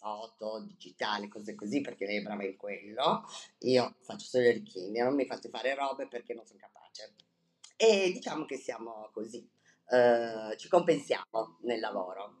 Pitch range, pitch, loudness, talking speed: 110-140 Hz, 115 Hz, -32 LUFS, 165 wpm